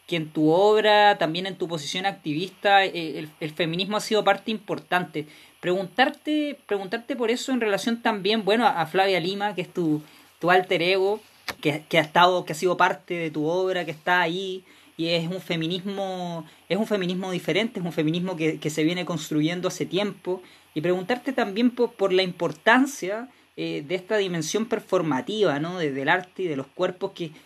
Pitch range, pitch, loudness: 165-205 Hz, 185 Hz, -24 LUFS